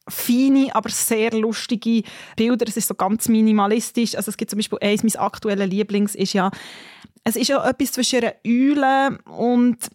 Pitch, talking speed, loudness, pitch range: 225 Hz, 170 wpm, -20 LUFS, 210-245 Hz